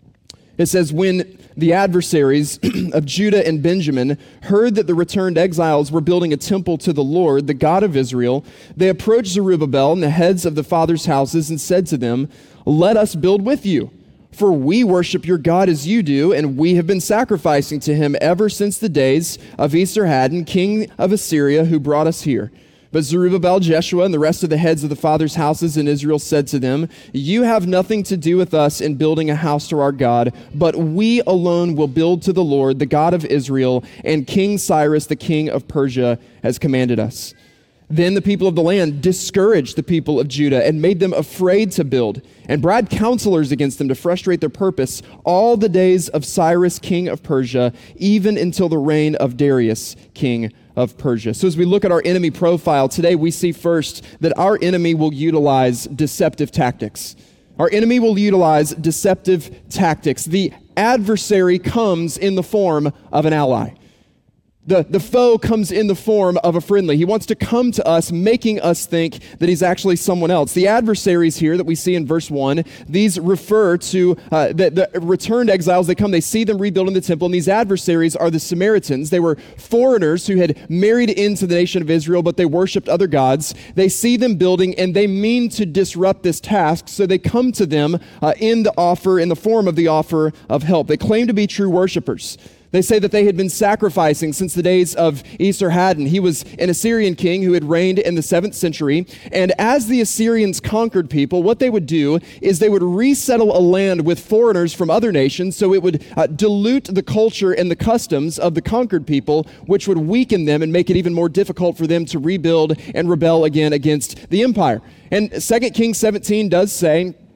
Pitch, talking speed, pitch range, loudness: 175 Hz, 200 wpm, 155-195 Hz, -16 LUFS